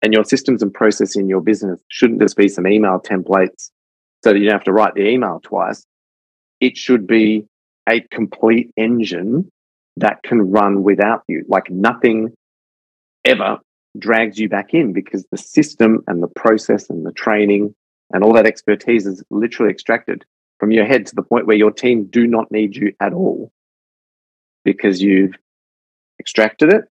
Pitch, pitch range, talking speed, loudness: 105 Hz, 100-110 Hz, 170 wpm, -15 LUFS